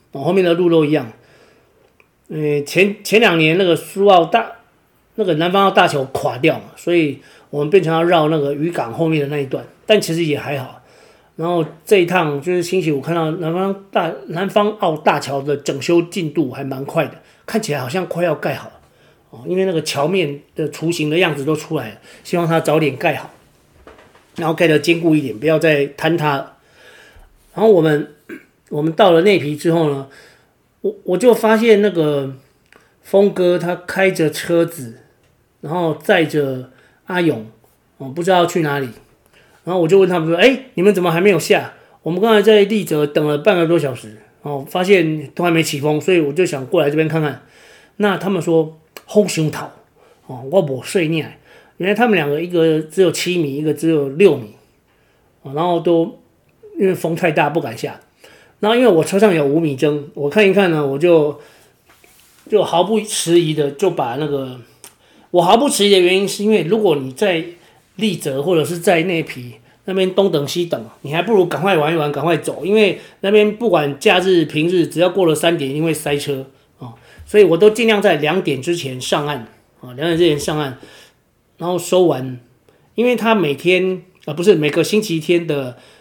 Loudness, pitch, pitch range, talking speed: -16 LUFS, 165 Hz, 145-185 Hz, 270 characters per minute